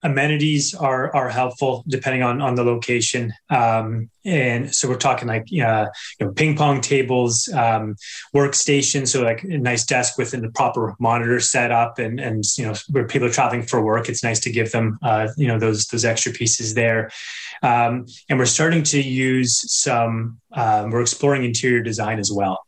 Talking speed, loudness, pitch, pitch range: 185 wpm, -19 LUFS, 120 Hz, 115-135 Hz